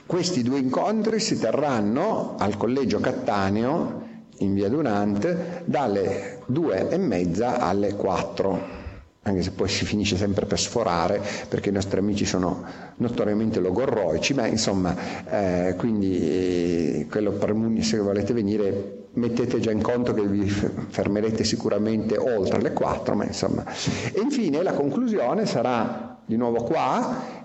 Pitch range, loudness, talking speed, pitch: 95-115 Hz, -24 LUFS, 135 wpm, 105 Hz